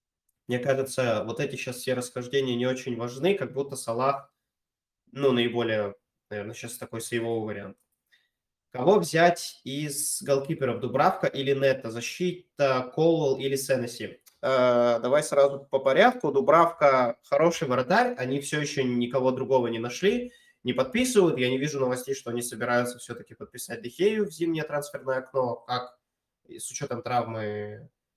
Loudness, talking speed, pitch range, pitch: -26 LUFS, 140 wpm, 120-145 Hz, 130 Hz